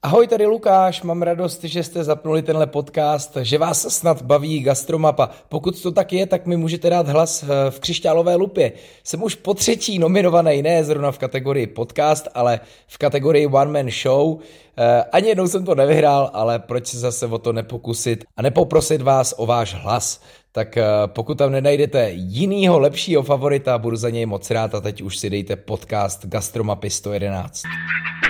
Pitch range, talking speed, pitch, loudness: 120-170 Hz, 170 wpm, 145 Hz, -19 LUFS